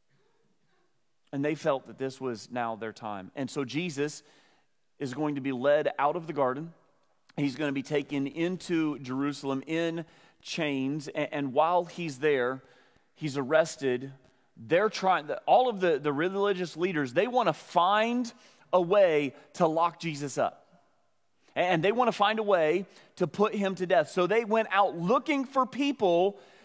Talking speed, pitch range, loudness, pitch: 170 wpm, 140-185 Hz, -28 LUFS, 160 Hz